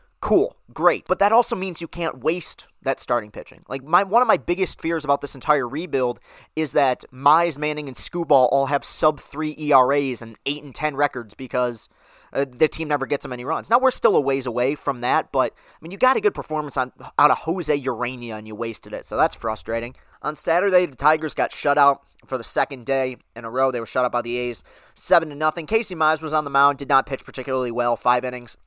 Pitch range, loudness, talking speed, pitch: 125-160 Hz, -22 LUFS, 235 wpm, 140 Hz